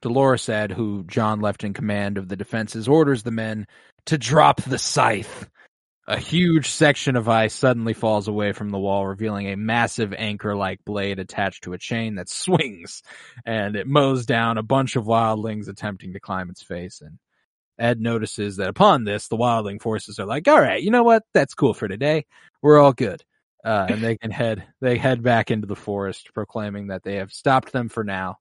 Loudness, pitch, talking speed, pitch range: -21 LUFS, 110 Hz, 200 wpm, 100-130 Hz